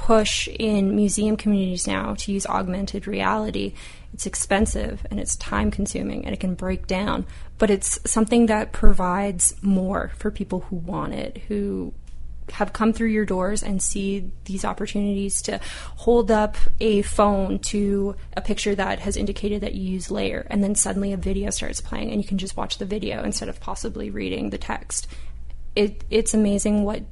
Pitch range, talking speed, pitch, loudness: 185-210 Hz, 175 wpm, 200 Hz, -24 LUFS